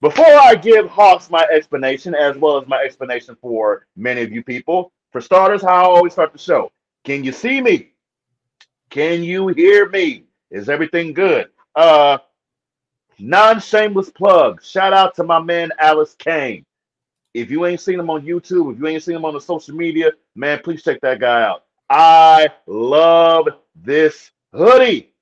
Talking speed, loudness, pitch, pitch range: 170 wpm, -13 LUFS, 170 Hz, 145-195 Hz